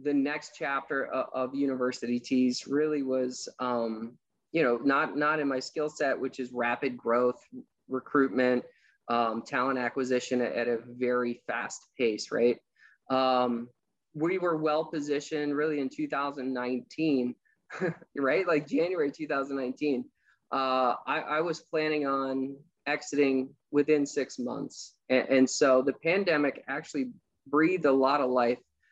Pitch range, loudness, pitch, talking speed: 125-150 Hz, -29 LUFS, 135 Hz, 145 wpm